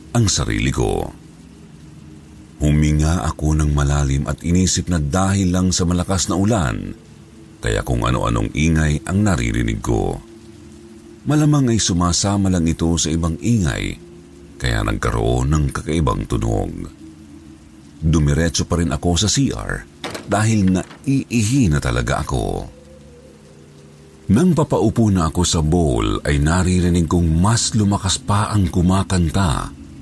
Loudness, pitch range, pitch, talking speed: -18 LUFS, 75-100 Hz, 90 Hz, 120 wpm